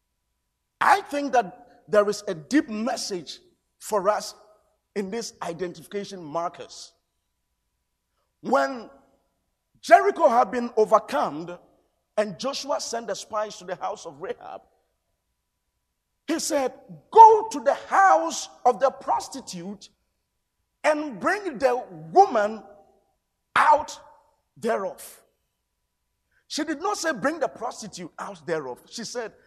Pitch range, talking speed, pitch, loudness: 185-290 Hz, 110 wpm, 215 Hz, -23 LUFS